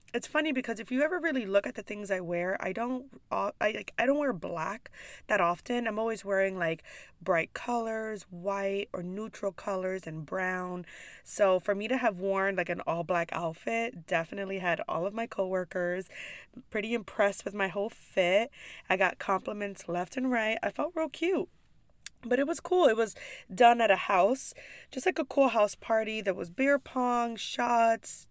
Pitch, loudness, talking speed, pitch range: 215 Hz, -30 LUFS, 190 wpm, 190-245 Hz